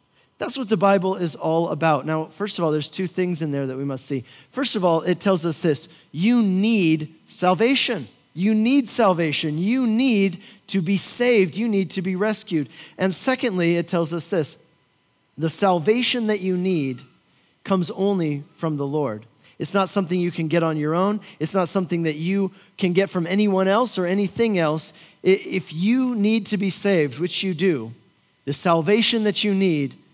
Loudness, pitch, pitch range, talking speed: -22 LUFS, 185 Hz, 160-200 Hz, 190 wpm